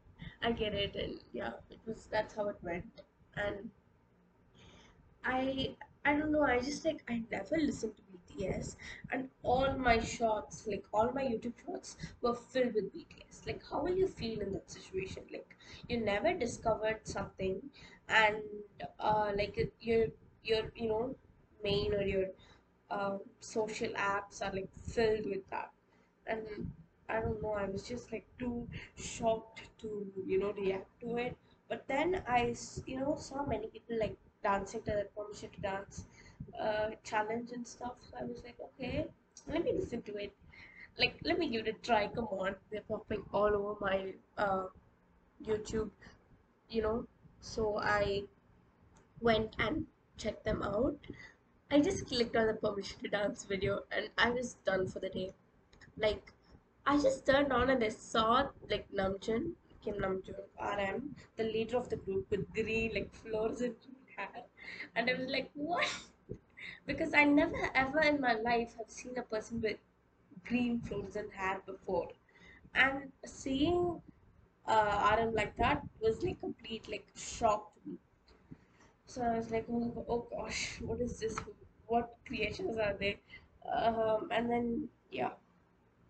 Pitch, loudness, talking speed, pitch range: 220 Hz, -36 LUFS, 160 wpm, 205-245 Hz